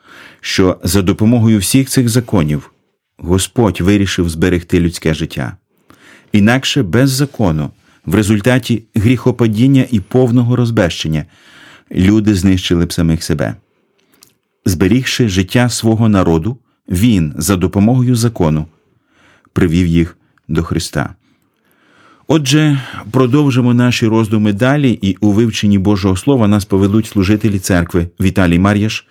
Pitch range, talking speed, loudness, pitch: 90-120 Hz, 110 wpm, -13 LUFS, 105 Hz